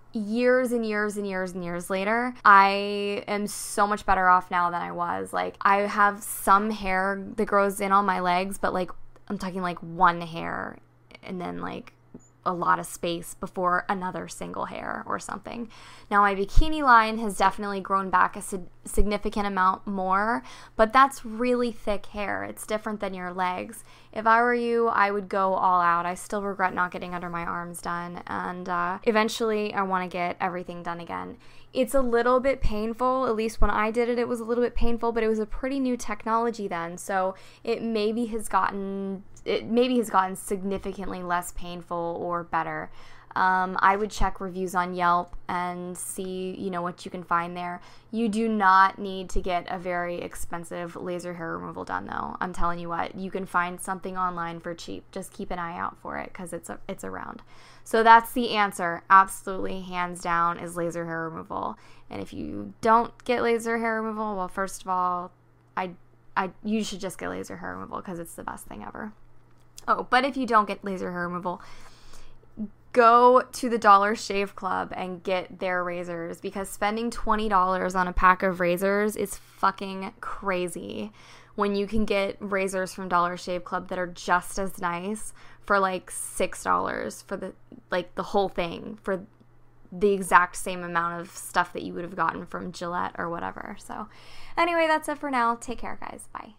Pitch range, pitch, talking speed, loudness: 180-215 Hz, 195 Hz, 190 wpm, -26 LUFS